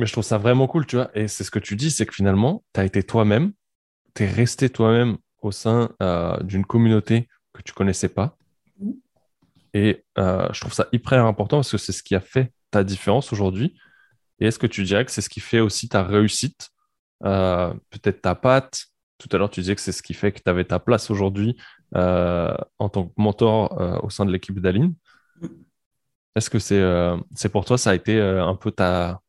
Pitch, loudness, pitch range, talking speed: 105 Hz, -22 LUFS, 95-120 Hz, 225 wpm